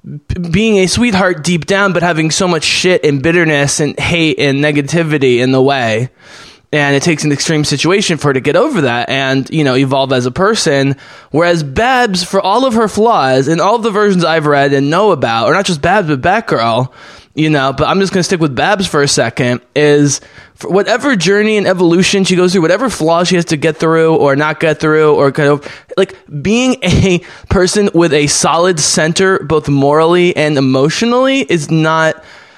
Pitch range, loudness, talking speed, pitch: 145-185 Hz, -11 LUFS, 205 wpm, 160 Hz